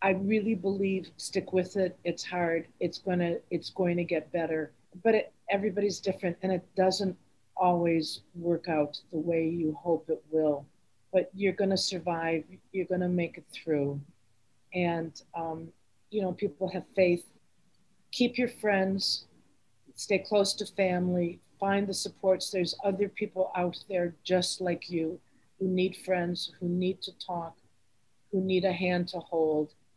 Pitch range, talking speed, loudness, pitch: 165-190 Hz, 160 wpm, -30 LUFS, 180 Hz